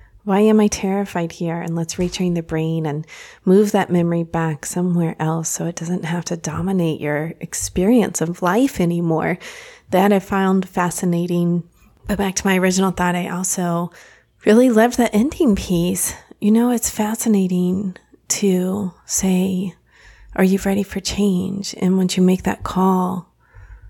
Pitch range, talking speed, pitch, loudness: 170-200 Hz, 155 wpm, 185 Hz, -19 LUFS